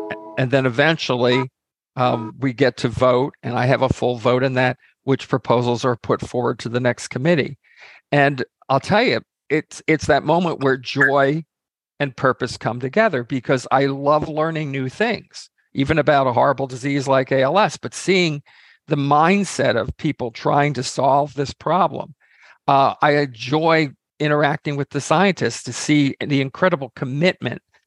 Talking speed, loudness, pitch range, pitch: 160 wpm, -19 LUFS, 125-150 Hz, 135 Hz